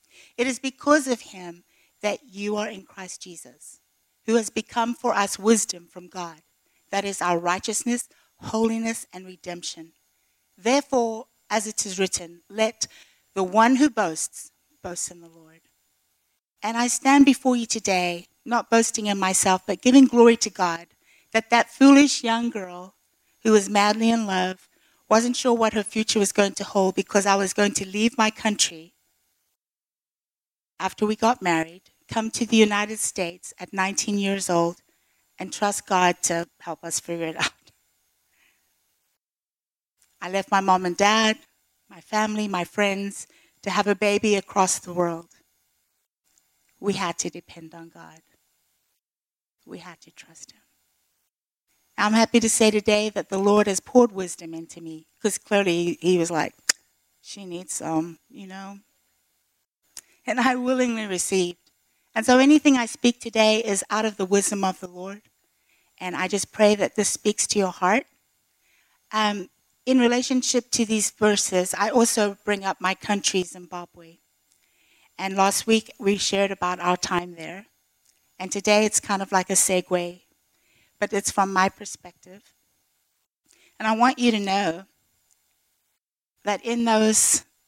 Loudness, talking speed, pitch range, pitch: -22 LUFS, 155 wpm, 175-220 Hz, 195 Hz